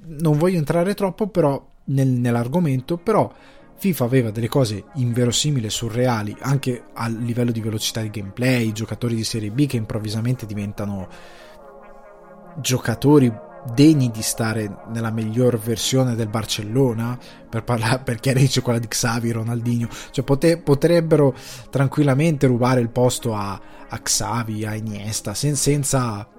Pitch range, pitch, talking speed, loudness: 115-140 Hz, 120 Hz, 135 wpm, -21 LUFS